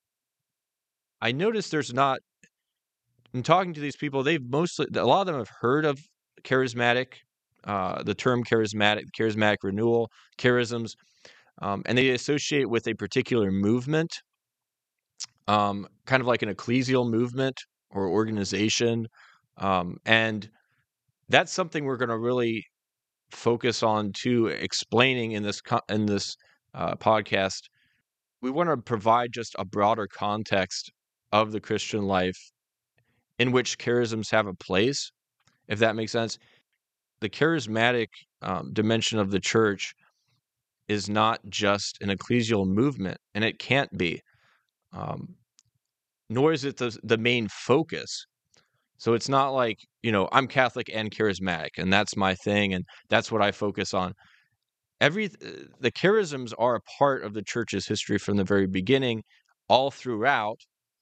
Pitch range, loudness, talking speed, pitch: 105-125 Hz, -26 LUFS, 140 wpm, 115 Hz